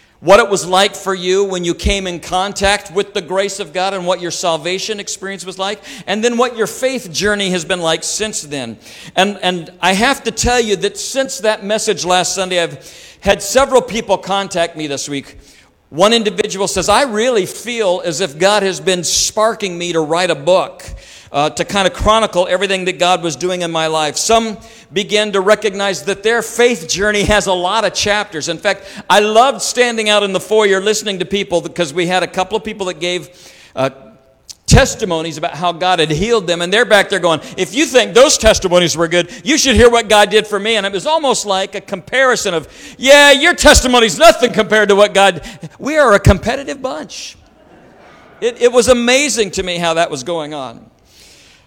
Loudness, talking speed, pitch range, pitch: -13 LUFS, 210 wpm, 180-215 Hz, 195 Hz